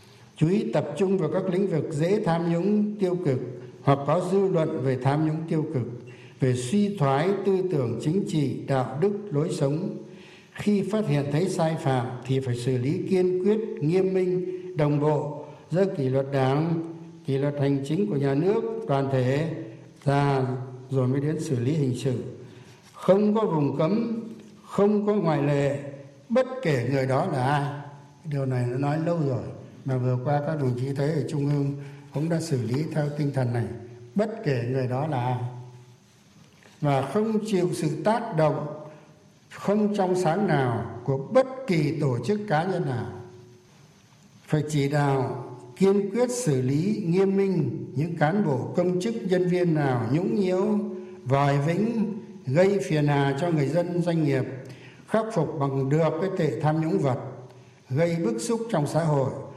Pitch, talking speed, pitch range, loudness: 150 Hz, 175 wpm, 135-185 Hz, -25 LUFS